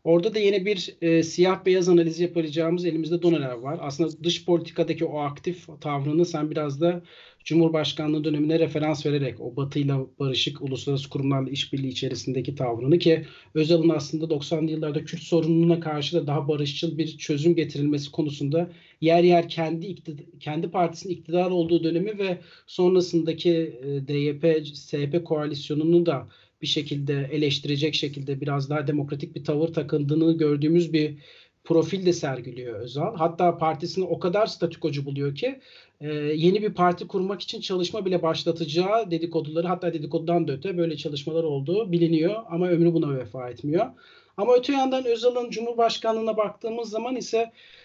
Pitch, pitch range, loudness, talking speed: 165 Hz, 150-175 Hz, -25 LUFS, 145 wpm